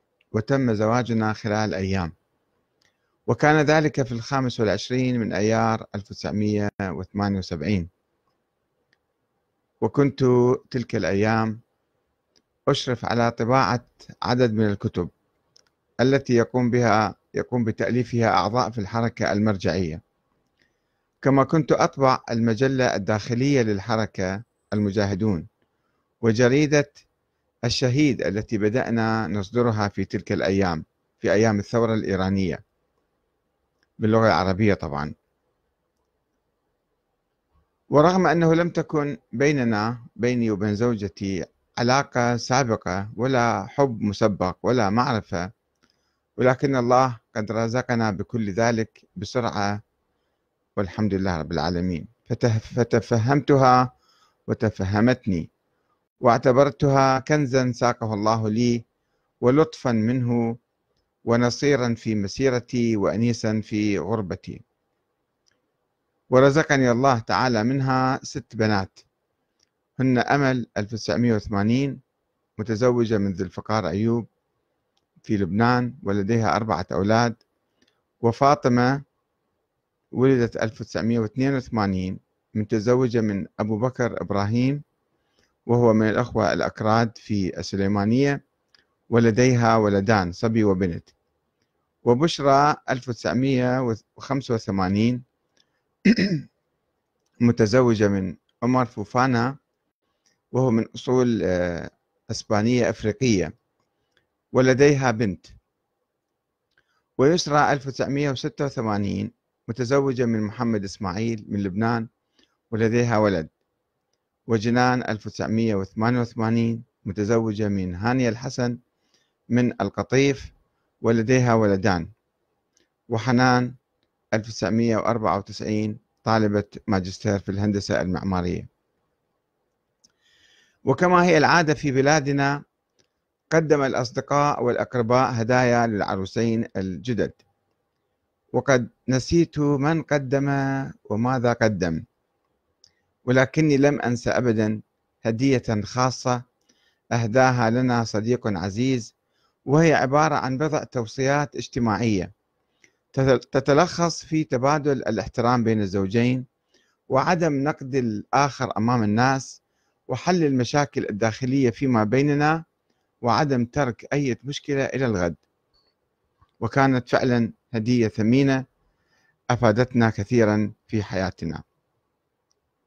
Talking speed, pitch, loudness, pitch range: 80 wpm, 115 Hz, -22 LUFS, 105-130 Hz